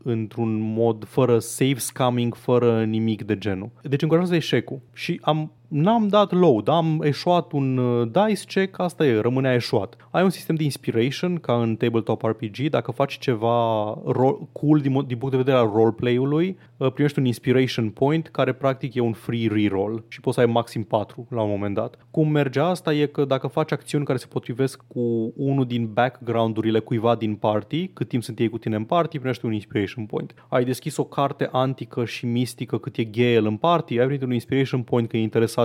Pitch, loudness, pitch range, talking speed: 125 Hz, -23 LUFS, 115-145 Hz, 200 wpm